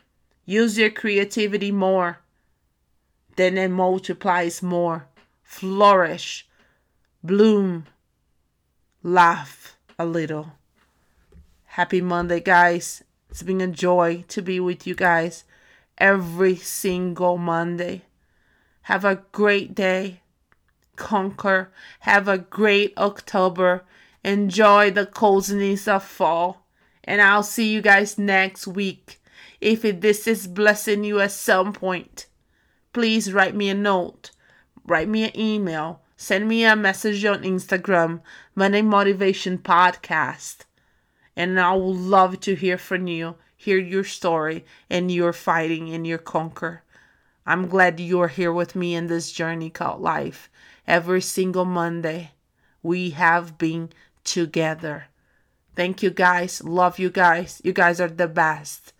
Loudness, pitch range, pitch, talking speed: -21 LUFS, 170-200 Hz, 185 Hz, 125 wpm